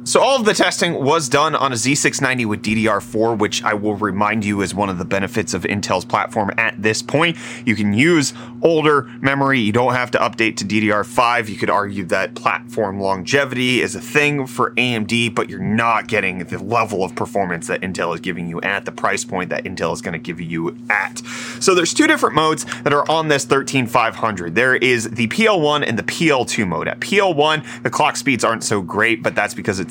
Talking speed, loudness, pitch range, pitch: 215 wpm, -18 LUFS, 105-140 Hz, 120 Hz